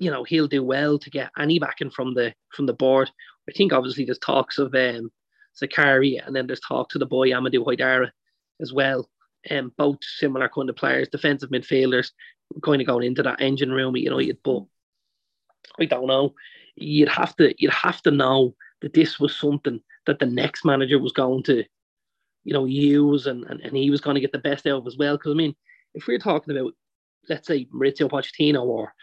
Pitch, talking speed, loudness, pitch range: 140 Hz, 210 wpm, -22 LUFS, 130-145 Hz